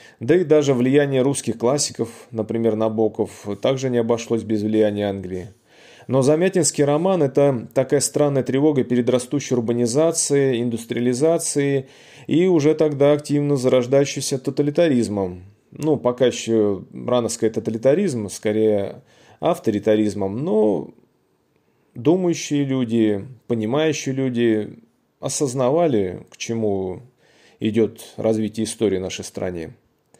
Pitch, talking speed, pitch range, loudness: 120 Hz, 105 wpm, 110-145 Hz, -20 LUFS